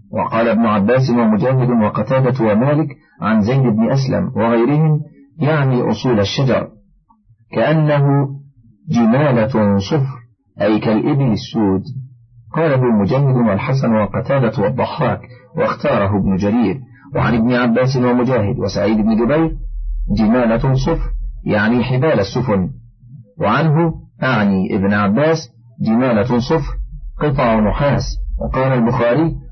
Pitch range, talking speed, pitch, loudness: 110-140 Hz, 105 wpm, 125 Hz, -16 LUFS